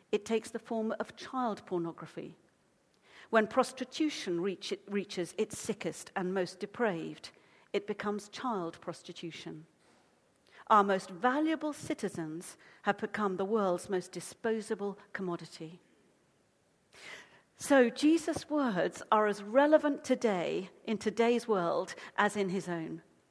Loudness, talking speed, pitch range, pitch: -33 LUFS, 120 wpm, 180-230 Hz, 205 Hz